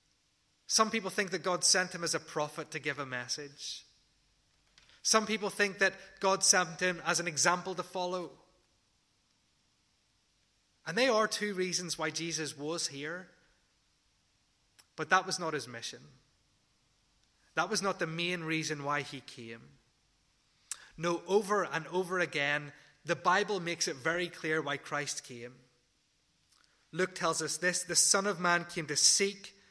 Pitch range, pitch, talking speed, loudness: 145-185 Hz, 165 Hz, 150 wpm, -31 LUFS